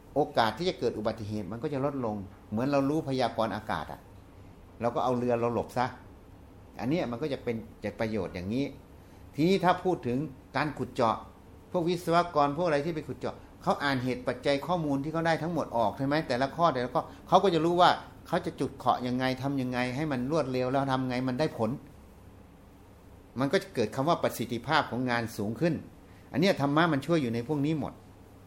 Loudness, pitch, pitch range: -30 LUFS, 125 Hz, 105-150 Hz